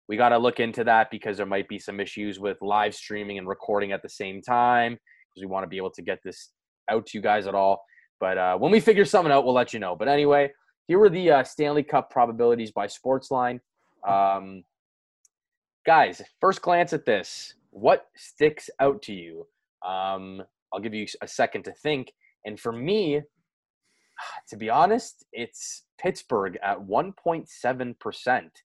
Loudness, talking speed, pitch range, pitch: -24 LUFS, 180 wpm, 100-140 Hz, 115 Hz